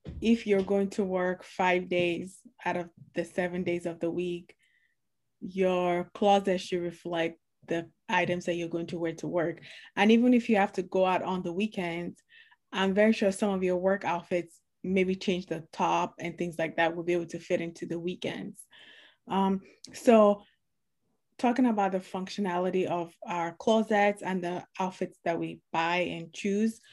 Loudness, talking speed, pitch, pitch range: -29 LUFS, 180 wpm, 180 Hz, 170-200 Hz